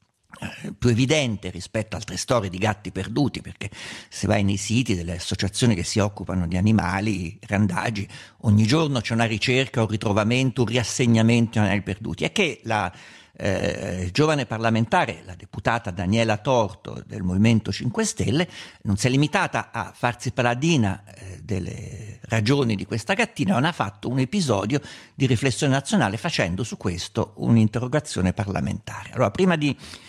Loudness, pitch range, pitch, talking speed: -23 LUFS, 100-125 Hz, 110 Hz, 150 wpm